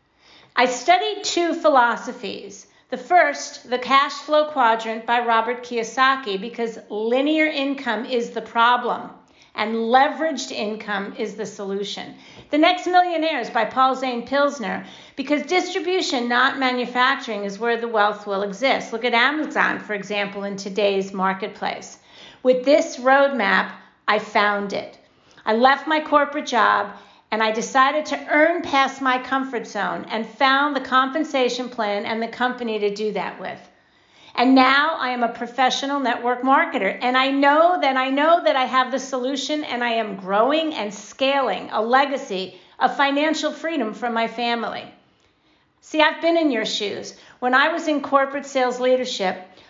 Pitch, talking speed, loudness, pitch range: 255 Hz, 155 wpm, -20 LUFS, 225-280 Hz